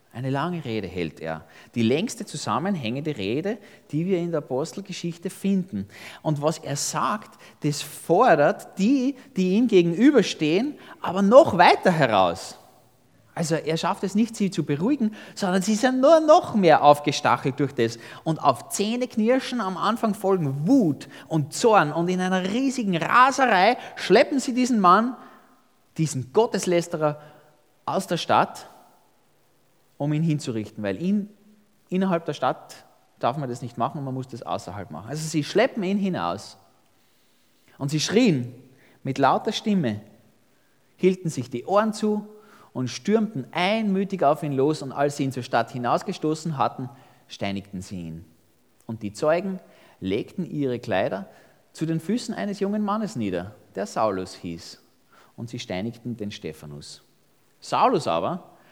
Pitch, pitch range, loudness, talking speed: 155 Hz, 125-200 Hz, -23 LUFS, 145 wpm